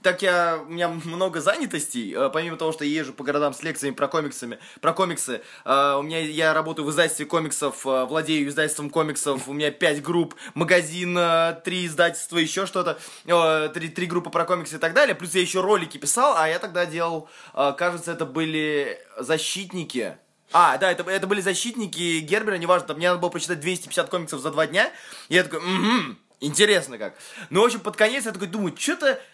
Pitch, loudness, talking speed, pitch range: 170 Hz, -23 LUFS, 185 wpm, 155-185 Hz